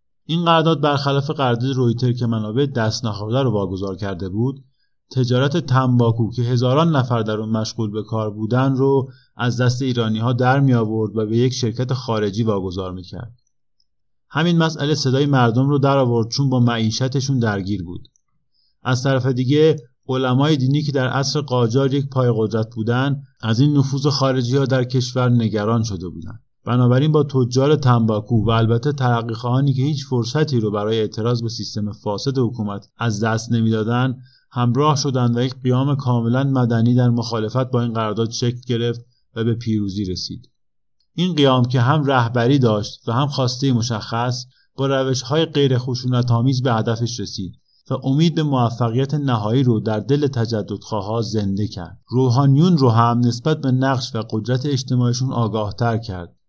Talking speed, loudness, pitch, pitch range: 165 wpm, -19 LUFS, 125 Hz, 115-135 Hz